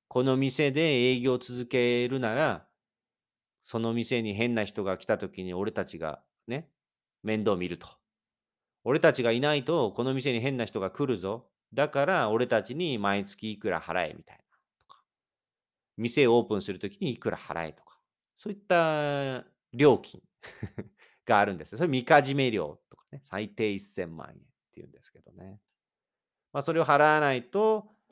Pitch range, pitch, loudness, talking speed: 110-145 Hz, 125 Hz, -28 LUFS, 295 characters per minute